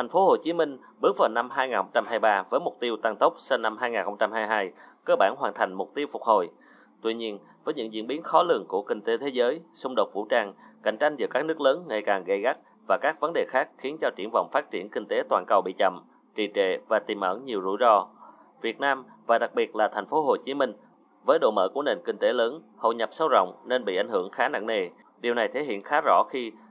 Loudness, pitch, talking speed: -26 LUFS, 165 Hz, 255 wpm